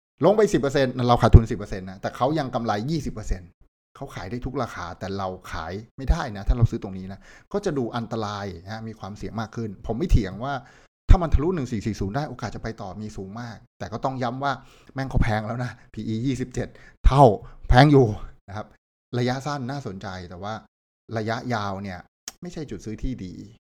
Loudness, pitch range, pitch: -25 LUFS, 100-125 Hz, 115 Hz